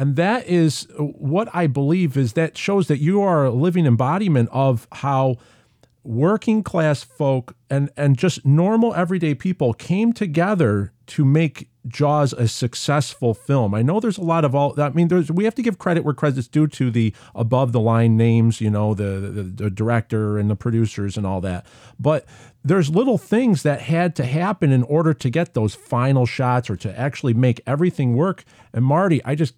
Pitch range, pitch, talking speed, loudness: 120-165 Hz, 140 Hz, 195 wpm, -20 LUFS